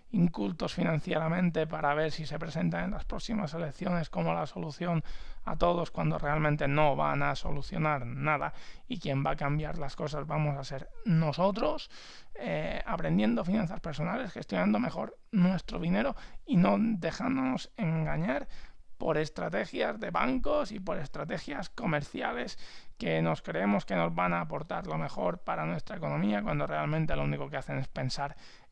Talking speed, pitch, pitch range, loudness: 155 wpm, 155 Hz, 140-180 Hz, -32 LUFS